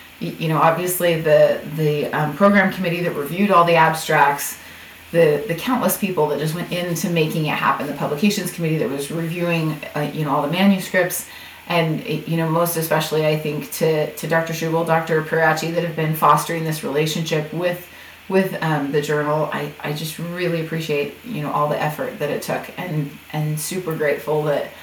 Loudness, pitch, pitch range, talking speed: -20 LUFS, 160 Hz, 150-170 Hz, 190 wpm